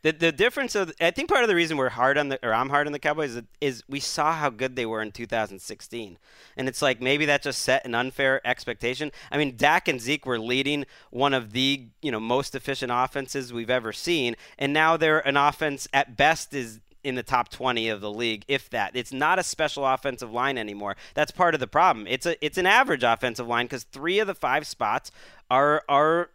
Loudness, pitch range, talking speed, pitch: -25 LUFS, 120-145 Hz, 230 wpm, 135 Hz